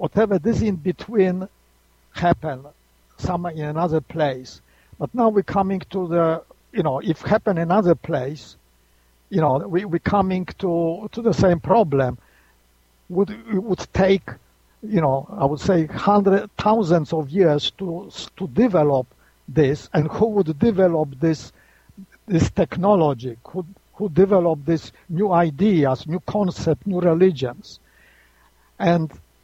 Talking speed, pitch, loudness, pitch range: 135 wpm, 170 Hz, -21 LUFS, 135-190 Hz